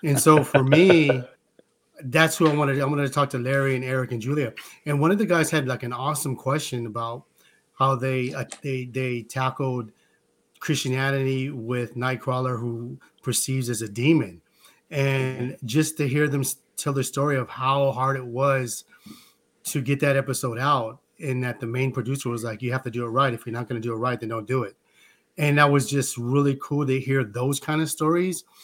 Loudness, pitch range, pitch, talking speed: -24 LUFS, 125-145 Hz, 135 Hz, 205 wpm